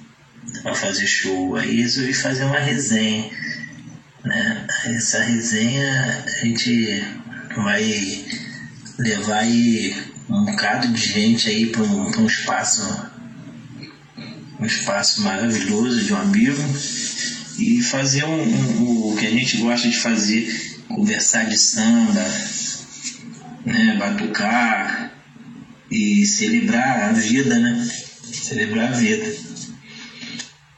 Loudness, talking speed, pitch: -19 LUFS, 110 wpm, 140 Hz